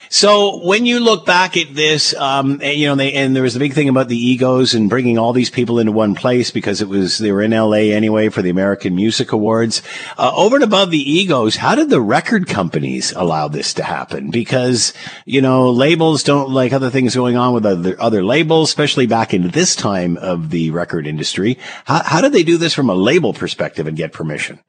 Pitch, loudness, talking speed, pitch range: 125 Hz, -14 LUFS, 230 wpm, 110-145 Hz